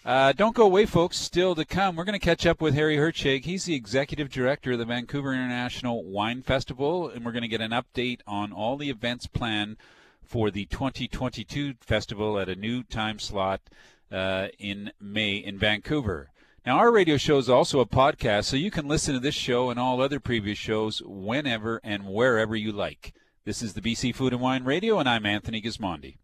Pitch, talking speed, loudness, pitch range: 125 Hz, 205 wpm, -26 LUFS, 110-140 Hz